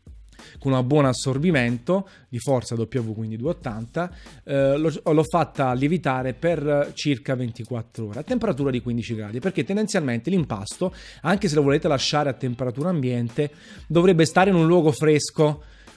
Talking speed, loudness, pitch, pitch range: 150 wpm, -23 LUFS, 145 Hz, 125-165 Hz